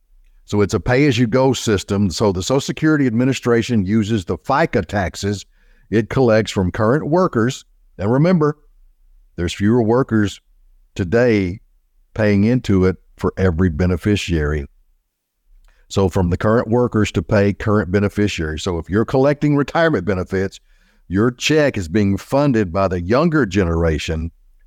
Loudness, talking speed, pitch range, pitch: -18 LUFS, 135 wpm, 90-120 Hz, 105 Hz